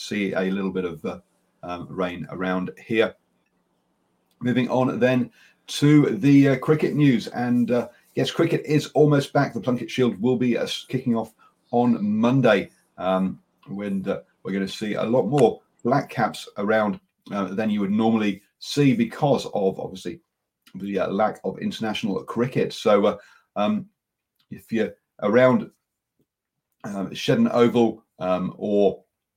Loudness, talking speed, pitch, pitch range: -23 LUFS, 150 wpm, 120 Hz, 100-130 Hz